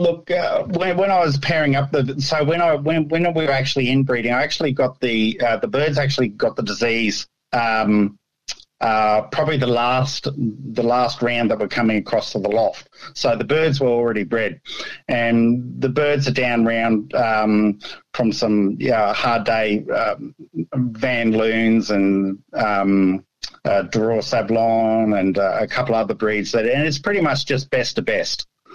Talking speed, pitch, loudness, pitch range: 175 wpm, 120 Hz, -19 LUFS, 110-140 Hz